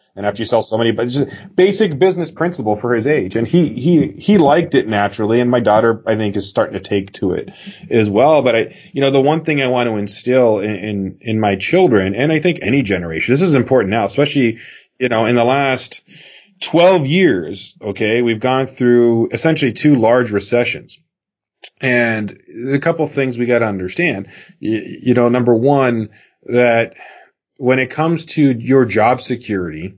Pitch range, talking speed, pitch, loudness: 110-145 Hz, 195 wpm, 125 Hz, -15 LUFS